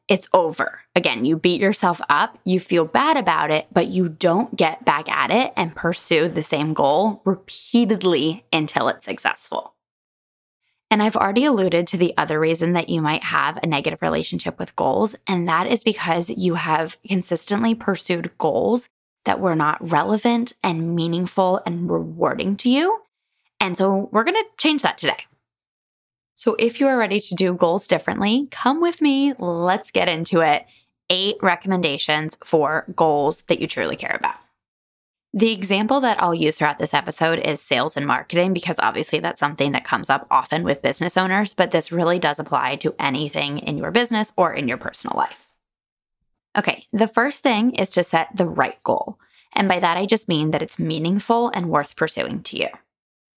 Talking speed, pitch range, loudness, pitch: 180 wpm, 160-220 Hz, -20 LUFS, 180 Hz